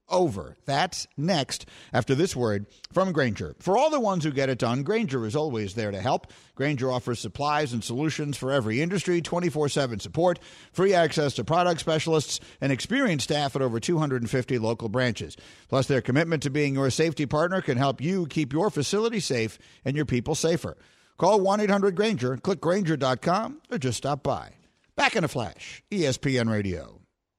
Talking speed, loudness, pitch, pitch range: 170 wpm, -26 LUFS, 145 Hz, 125-170 Hz